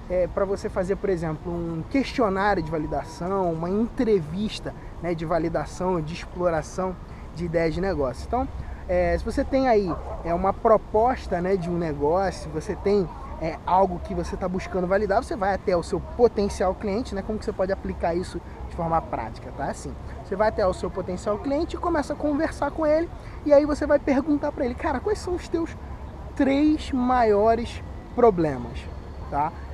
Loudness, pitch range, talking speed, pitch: -25 LUFS, 180-250 Hz, 185 wpm, 200 Hz